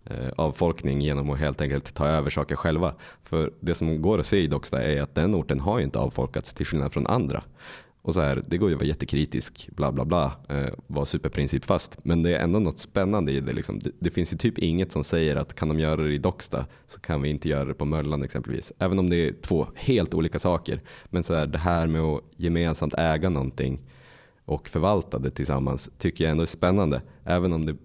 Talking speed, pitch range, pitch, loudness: 230 wpm, 70-85 Hz, 80 Hz, -26 LUFS